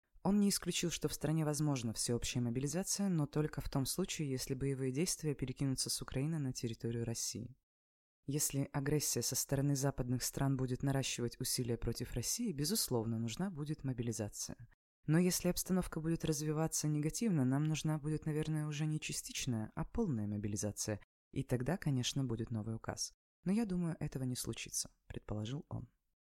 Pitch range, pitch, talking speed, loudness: 120-155 Hz, 135 Hz, 155 wpm, -38 LUFS